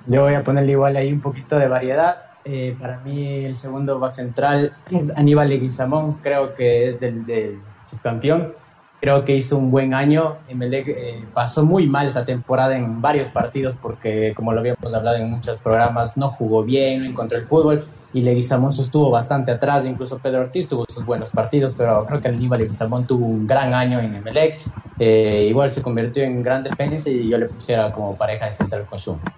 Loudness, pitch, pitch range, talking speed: -19 LUFS, 130 Hz, 115-140 Hz, 190 wpm